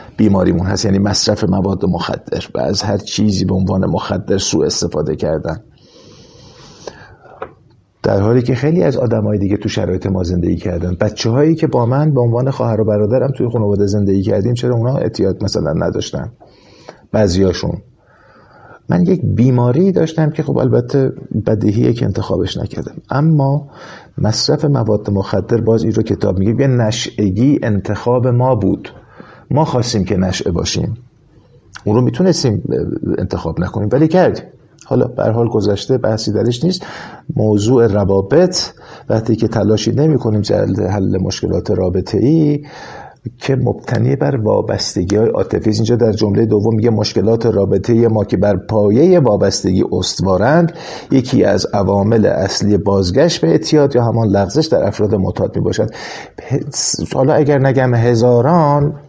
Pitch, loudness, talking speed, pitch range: 115 Hz, -14 LUFS, 140 wpm, 100-135 Hz